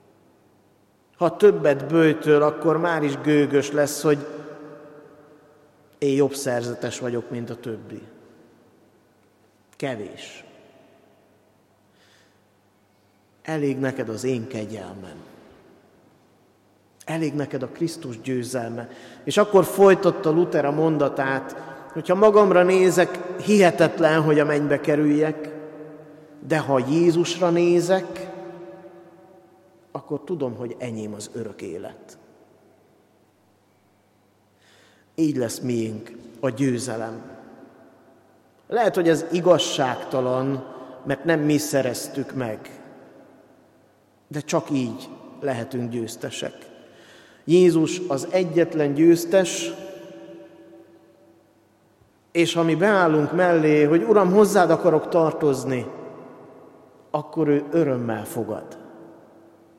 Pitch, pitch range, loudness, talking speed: 145 Hz, 120-165 Hz, -21 LUFS, 90 wpm